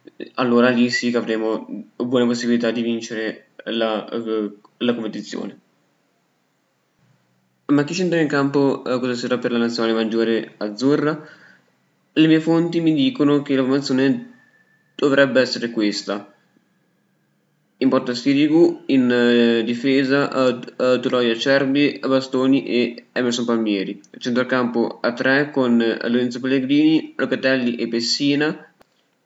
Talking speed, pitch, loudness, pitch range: 120 wpm, 125 Hz, -19 LUFS, 115-140 Hz